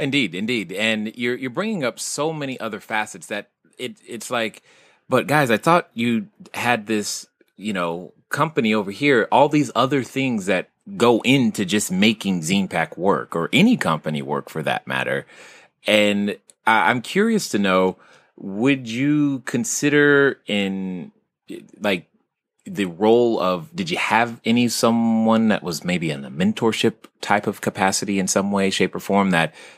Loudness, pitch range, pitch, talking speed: -20 LUFS, 100-145 Hz, 115 Hz, 160 wpm